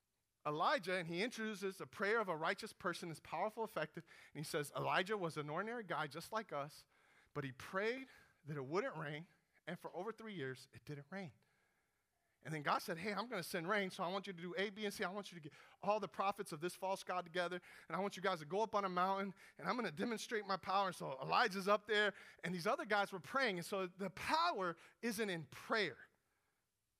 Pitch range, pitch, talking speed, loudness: 170-210 Hz, 190 Hz, 240 wpm, -42 LUFS